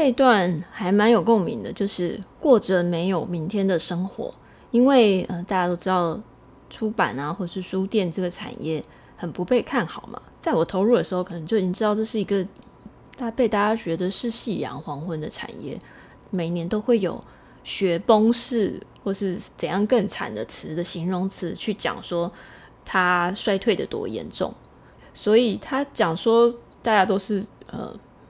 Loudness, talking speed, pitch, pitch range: -23 LUFS, 250 characters per minute, 195 Hz, 175-225 Hz